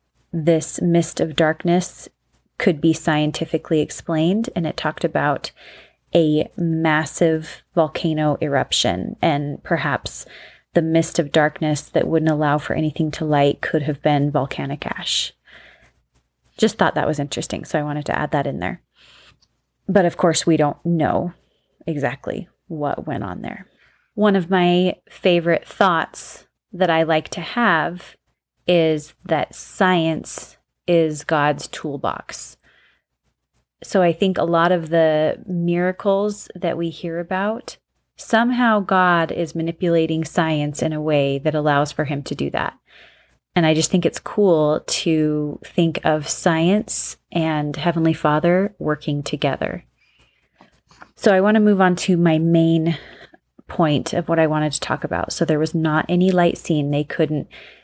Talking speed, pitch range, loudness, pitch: 145 wpm, 155-175 Hz, -20 LUFS, 165 Hz